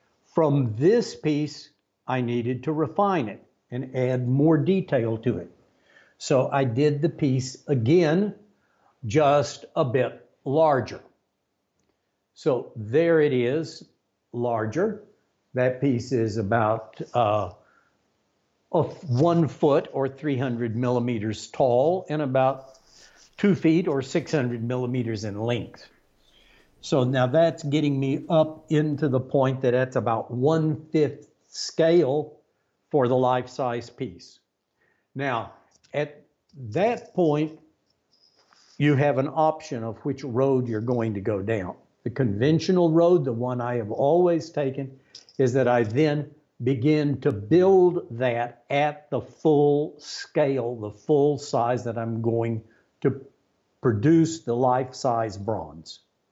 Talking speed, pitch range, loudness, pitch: 125 wpm, 120-155 Hz, -24 LUFS, 135 Hz